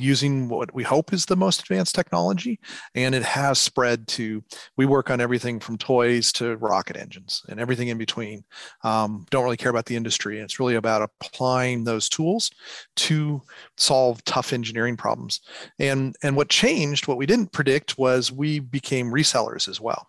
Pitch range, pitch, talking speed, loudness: 115-145 Hz, 130 Hz, 180 wpm, -23 LUFS